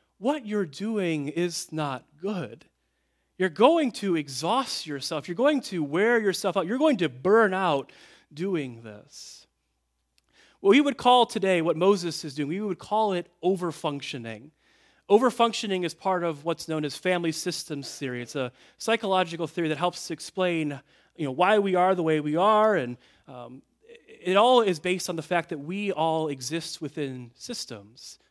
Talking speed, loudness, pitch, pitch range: 165 wpm, -26 LUFS, 175 Hz, 150-195 Hz